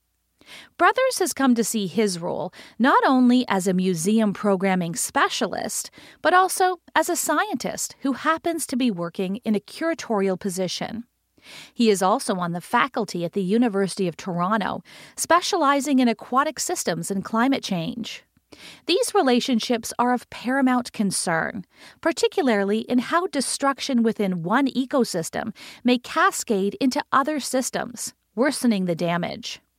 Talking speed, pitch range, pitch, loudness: 135 wpm, 200-280 Hz, 240 Hz, -22 LUFS